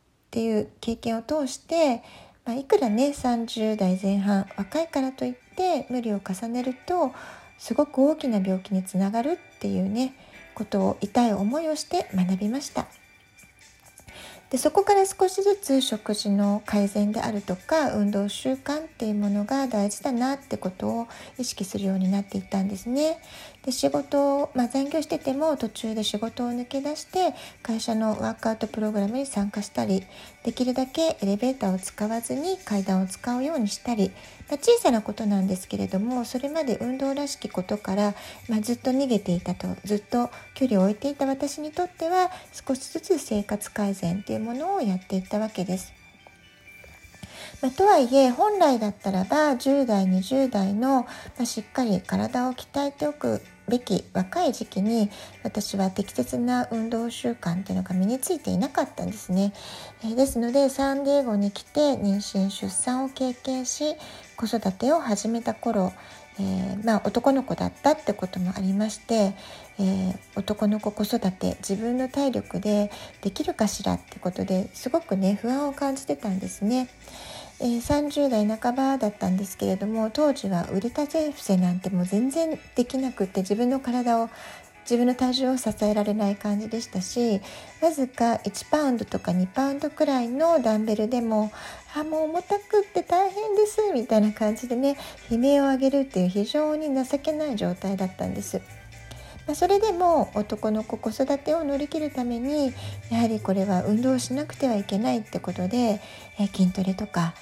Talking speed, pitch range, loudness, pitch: 340 characters per minute, 200-275 Hz, -26 LUFS, 230 Hz